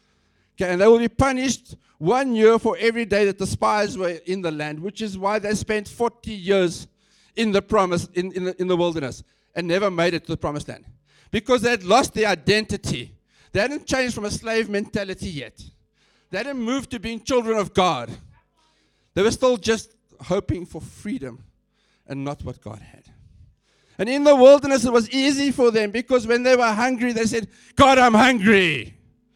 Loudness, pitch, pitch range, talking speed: -20 LUFS, 210 Hz, 180-240 Hz, 195 wpm